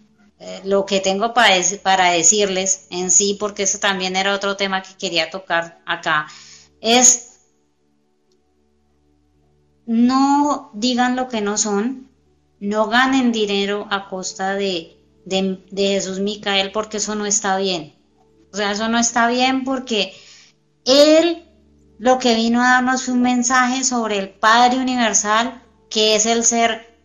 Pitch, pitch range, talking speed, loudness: 200 Hz, 185-235 Hz, 145 wpm, -17 LUFS